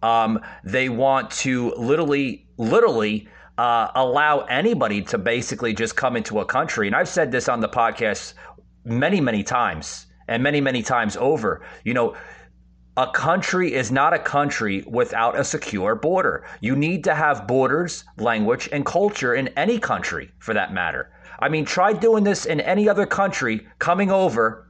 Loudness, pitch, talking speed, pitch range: -21 LUFS, 135 Hz, 165 wpm, 115-170 Hz